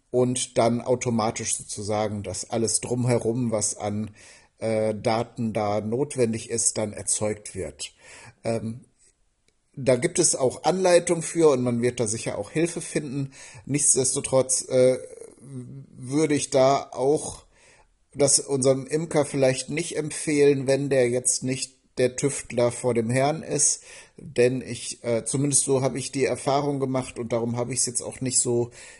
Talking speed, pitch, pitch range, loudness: 150 wpm, 130 Hz, 115-140 Hz, -24 LUFS